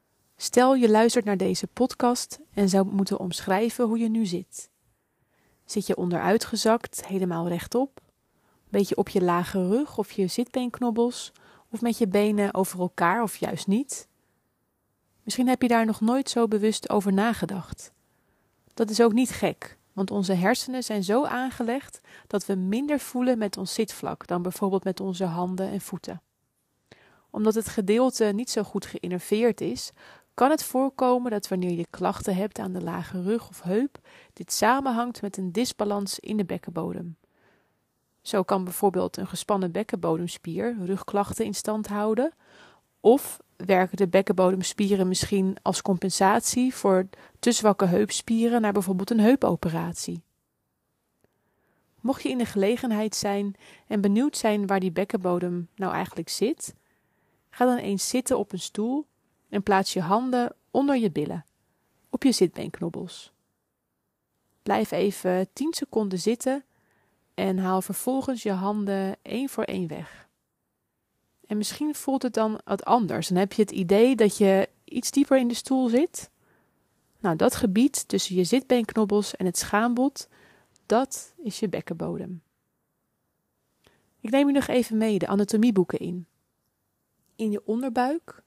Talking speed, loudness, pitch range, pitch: 145 wpm, -25 LUFS, 190-240 Hz, 210 Hz